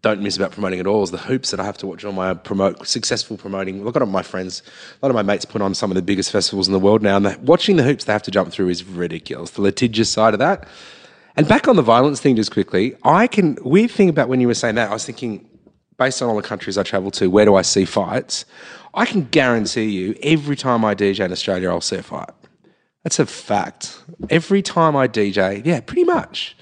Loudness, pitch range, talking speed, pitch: -18 LUFS, 95-135 Hz, 255 wpm, 105 Hz